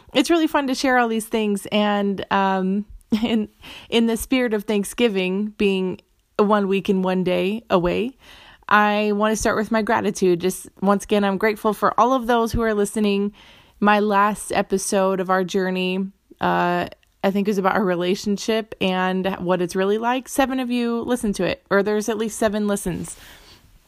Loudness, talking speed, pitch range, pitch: -21 LUFS, 180 wpm, 190-220 Hz, 205 Hz